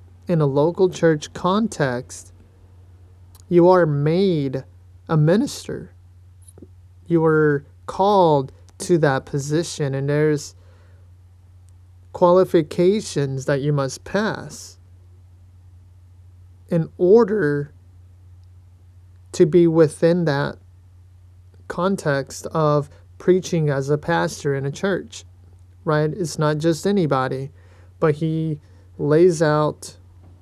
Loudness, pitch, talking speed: -20 LUFS, 135 Hz, 90 wpm